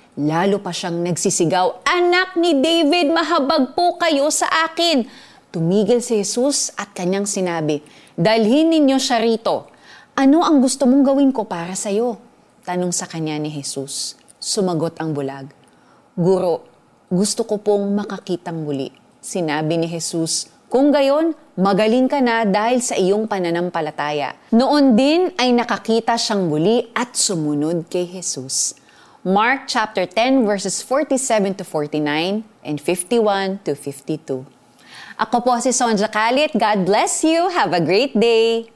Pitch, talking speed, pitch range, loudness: 215 Hz, 140 wpm, 175-265 Hz, -18 LUFS